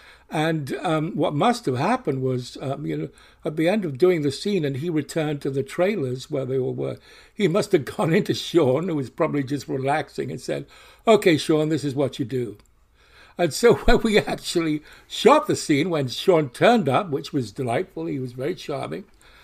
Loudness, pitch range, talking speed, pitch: -23 LUFS, 135-170 Hz, 205 wpm, 150 Hz